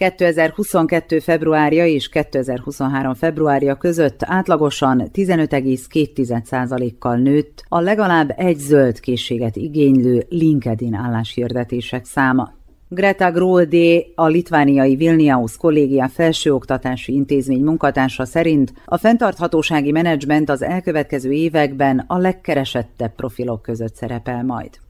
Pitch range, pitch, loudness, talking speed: 130-165 Hz, 145 Hz, -17 LUFS, 95 wpm